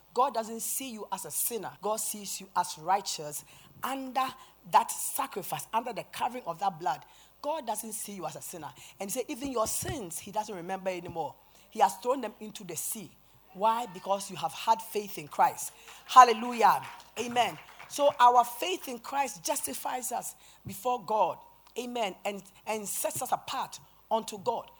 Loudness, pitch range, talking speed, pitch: -30 LUFS, 190-245 Hz, 175 wpm, 215 Hz